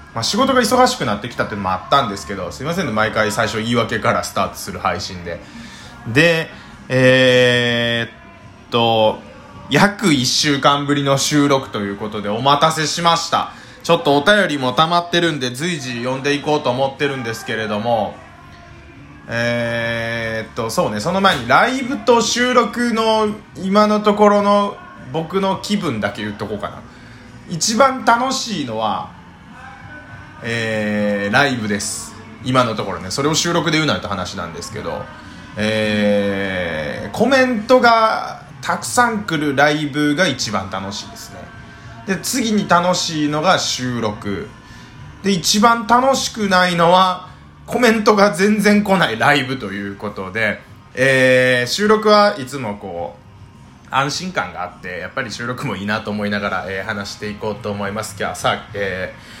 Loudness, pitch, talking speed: -17 LUFS, 135 Hz, 305 characters per minute